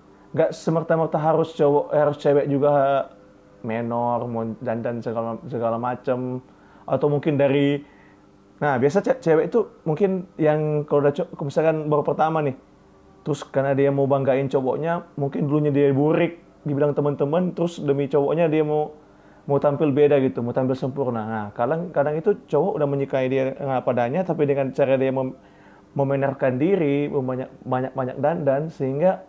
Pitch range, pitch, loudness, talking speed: 130-155 Hz, 140 Hz, -22 LUFS, 155 wpm